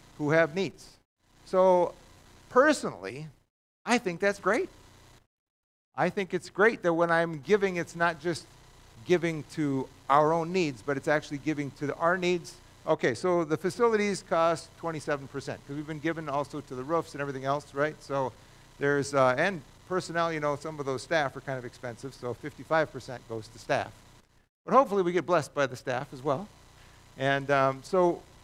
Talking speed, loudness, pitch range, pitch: 175 wpm, -29 LUFS, 135-170 Hz, 150 Hz